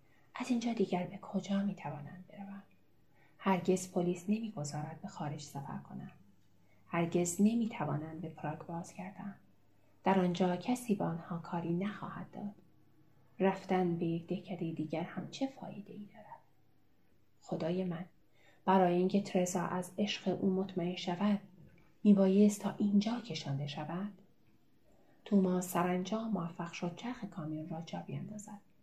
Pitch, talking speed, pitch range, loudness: 180 Hz, 135 wpm, 155-195 Hz, -35 LUFS